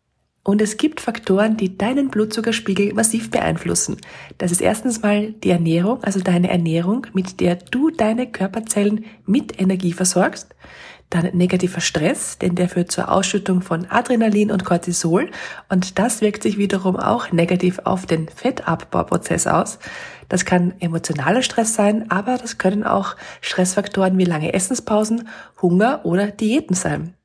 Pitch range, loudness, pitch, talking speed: 180-220 Hz, -19 LUFS, 195 Hz, 145 wpm